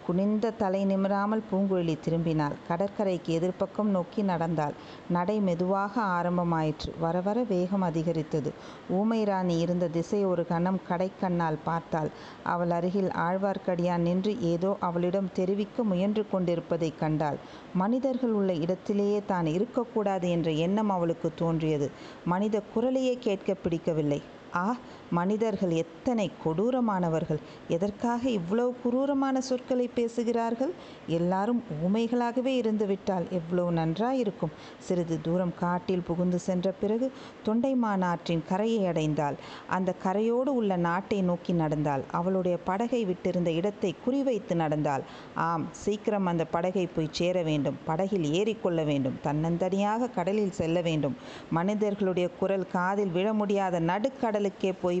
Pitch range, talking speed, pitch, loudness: 170-210 Hz, 110 wpm, 185 Hz, -29 LUFS